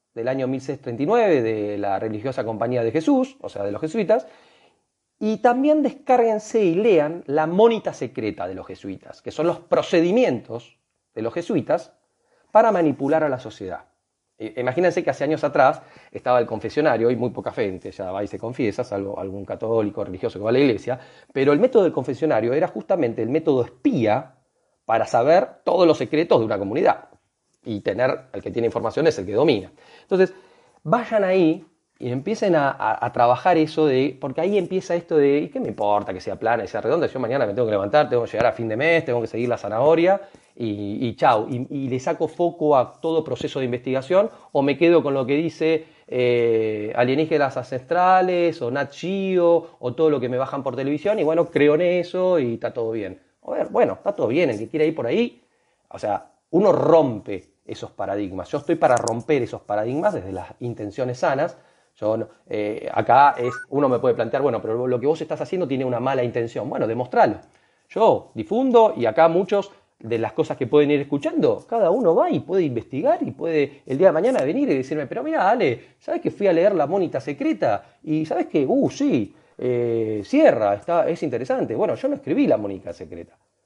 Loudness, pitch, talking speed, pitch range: -21 LUFS, 145 Hz, 200 wpm, 120-175 Hz